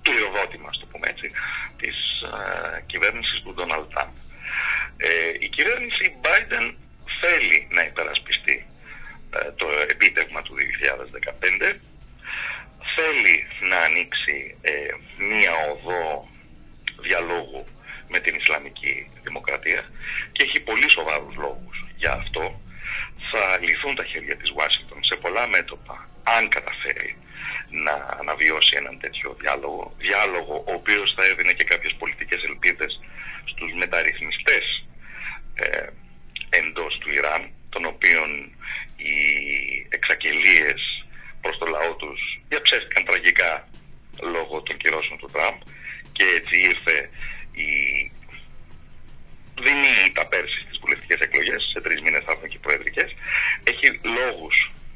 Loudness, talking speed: -21 LUFS, 110 wpm